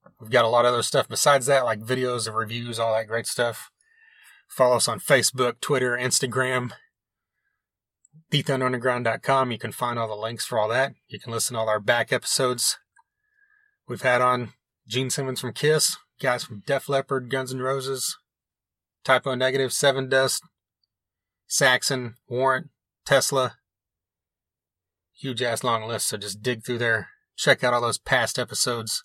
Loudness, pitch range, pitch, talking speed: -23 LUFS, 115-135 Hz, 125 Hz, 160 wpm